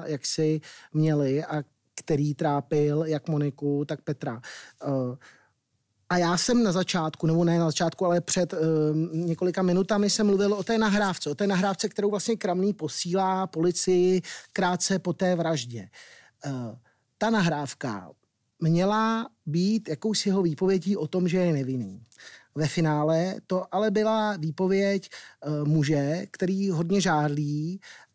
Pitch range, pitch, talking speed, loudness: 150-190 Hz, 170 Hz, 140 wpm, -26 LUFS